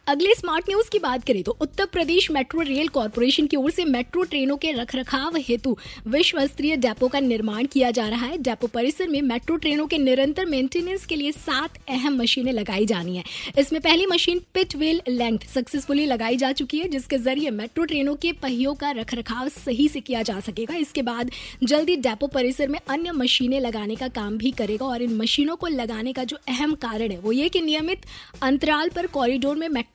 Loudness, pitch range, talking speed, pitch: -23 LUFS, 245-310 Hz, 200 wpm, 275 Hz